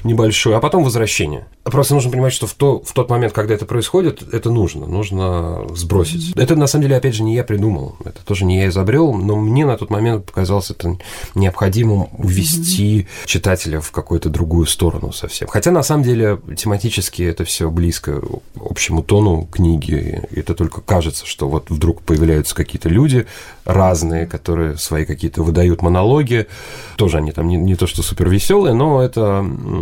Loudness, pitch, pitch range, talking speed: -16 LUFS, 95 Hz, 85-115 Hz, 175 wpm